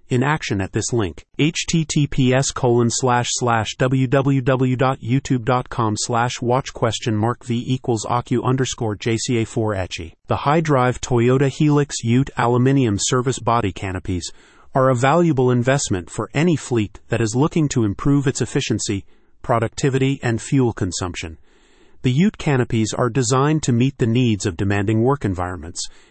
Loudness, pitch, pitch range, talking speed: -19 LUFS, 125 Hz, 110-135 Hz, 130 wpm